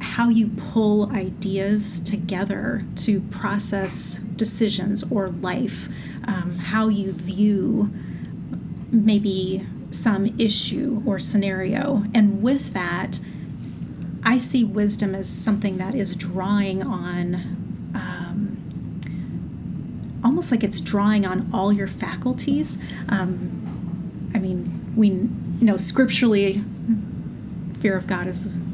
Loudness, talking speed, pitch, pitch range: -21 LUFS, 105 wpm, 200 Hz, 190-215 Hz